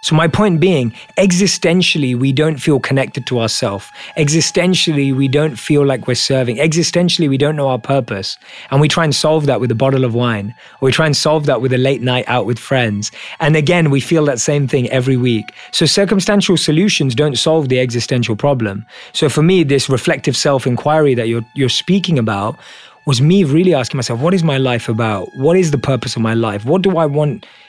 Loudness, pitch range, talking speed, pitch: -14 LUFS, 125-160 Hz, 210 wpm, 140 Hz